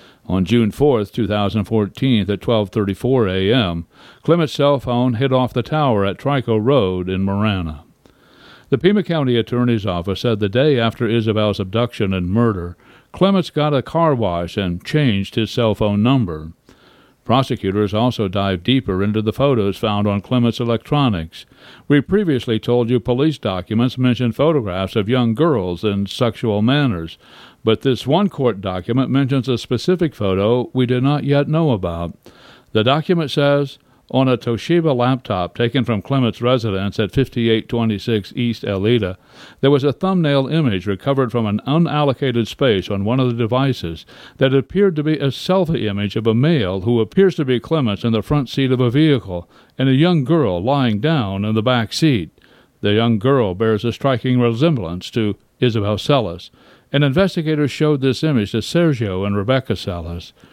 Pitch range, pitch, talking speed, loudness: 105-140 Hz, 120 Hz, 165 wpm, -18 LUFS